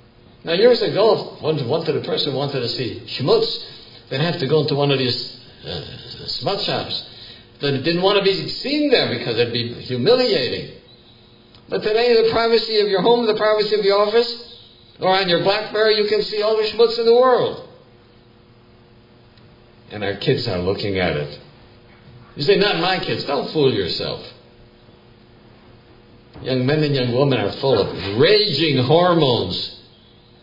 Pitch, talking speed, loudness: 135 Hz, 165 wpm, -18 LUFS